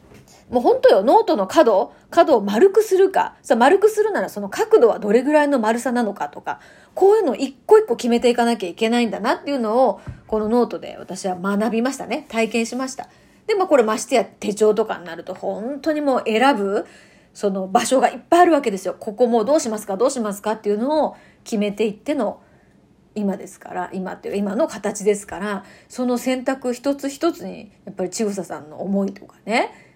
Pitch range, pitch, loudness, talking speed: 205-280 Hz, 235 Hz, -19 LUFS, 420 characters per minute